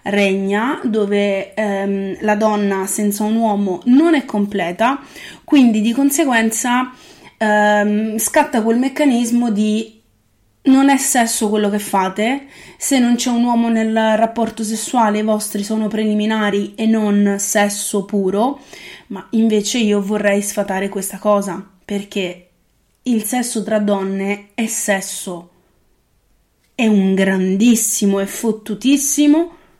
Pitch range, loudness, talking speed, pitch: 200-240 Hz, -16 LUFS, 120 wpm, 215 Hz